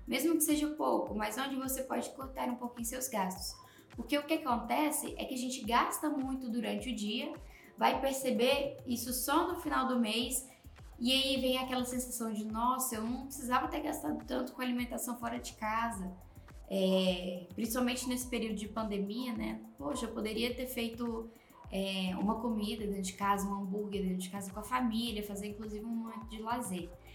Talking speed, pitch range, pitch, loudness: 185 wpm, 215-255 Hz, 240 Hz, -35 LUFS